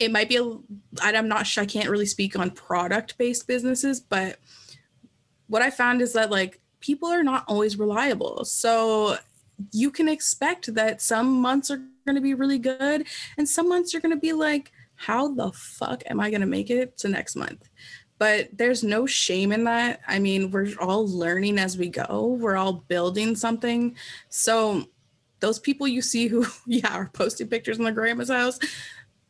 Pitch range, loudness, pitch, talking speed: 205-260 Hz, -24 LUFS, 230 Hz, 180 wpm